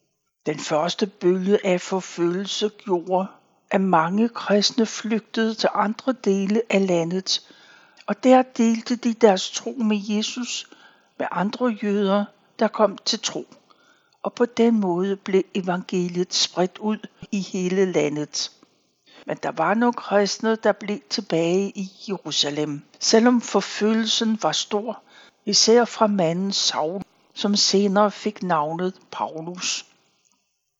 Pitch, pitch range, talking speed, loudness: 205 Hz, 185-225 Hz, 125 wpm, -22 LUFS